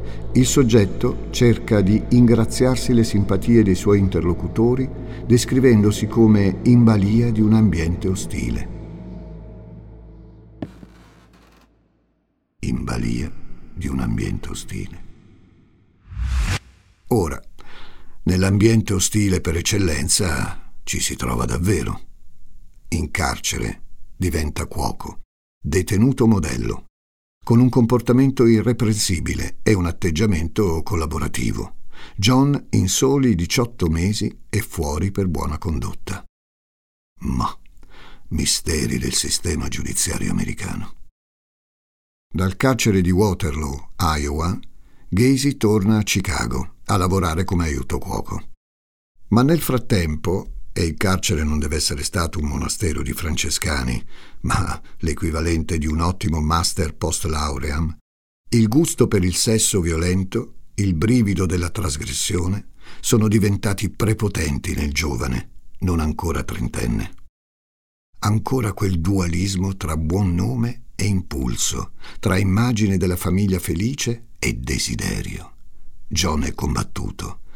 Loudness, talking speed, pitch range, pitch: -20 LUFS, 105 wpm, 80-110 Hz, 95 Hz